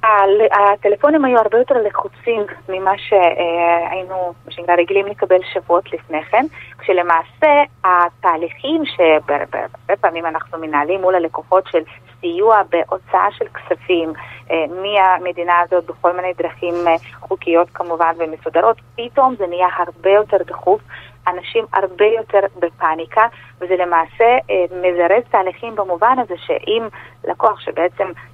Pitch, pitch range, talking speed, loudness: 180 Hz, 170-205 Hz, 110 wpm, -16 LUFS